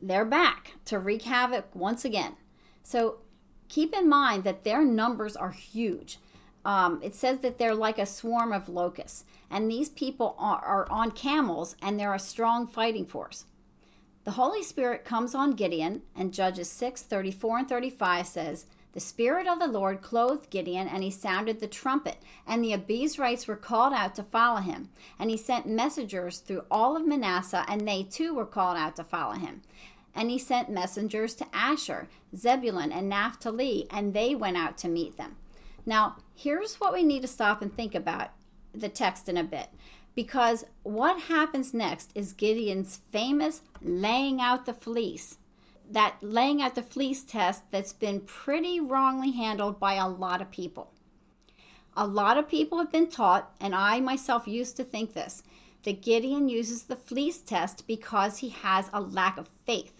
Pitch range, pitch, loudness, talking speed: 195-255 Hz, 225 Hz, -29 LUFS, 175 wpm